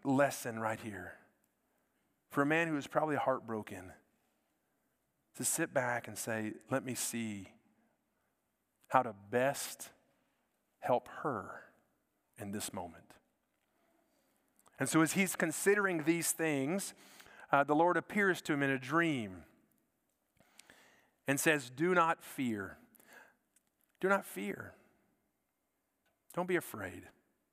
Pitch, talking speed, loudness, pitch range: 140 Hz, 115 wpm, -35 LUFS, 120-165 Hz